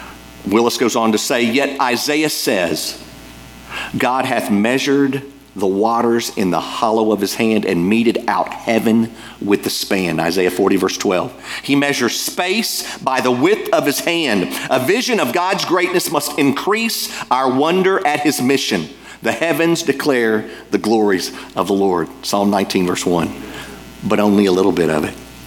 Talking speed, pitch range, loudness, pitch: 165 wpm, 105-150 Hz, -16 LUFS, 120 Hz